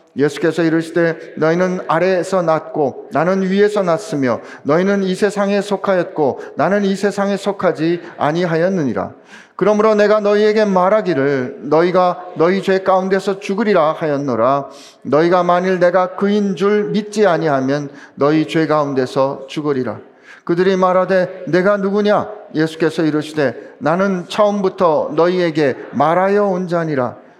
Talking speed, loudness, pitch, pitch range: 320 characters per minute, -16 LUFS, 180 Hz, 155-200 Hz